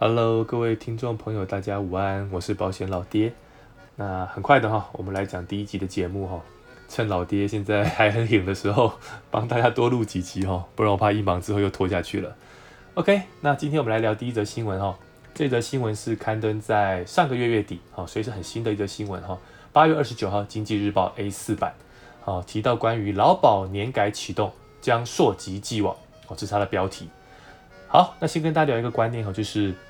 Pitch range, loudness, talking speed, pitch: 95-115 Hz, -24 LUFS, 320 characters per minute, 105 Hz